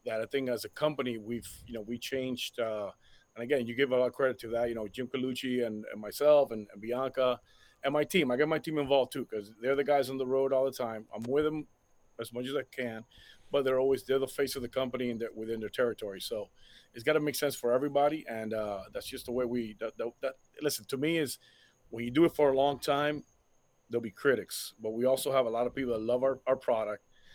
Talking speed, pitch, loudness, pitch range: 260 wpm, 130 Hz, -32 LUFS, 115-140 Hz